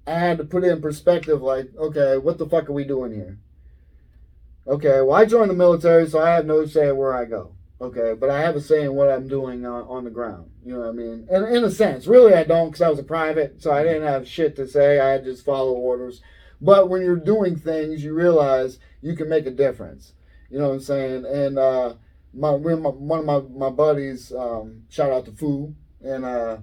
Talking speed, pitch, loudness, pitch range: 235 wpm, 140 Hz, -20 LUFS, 125-160 Hz